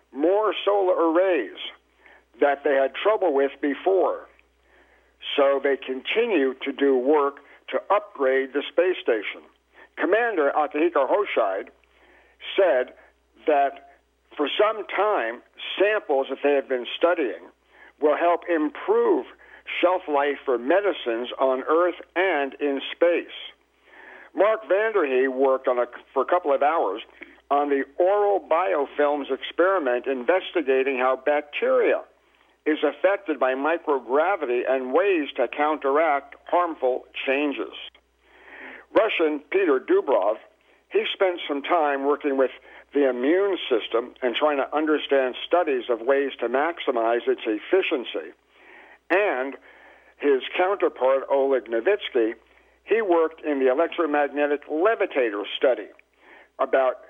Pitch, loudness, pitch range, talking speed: 145 Hz, -23 LUFS, 135-185 Hz, 115 wpm